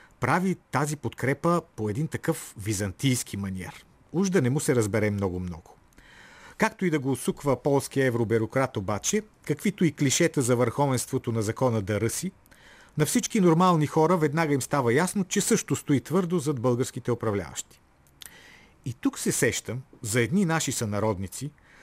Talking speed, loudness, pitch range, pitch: 150 wpm, -26 LUFS, 115-165 Hz, 135 Hz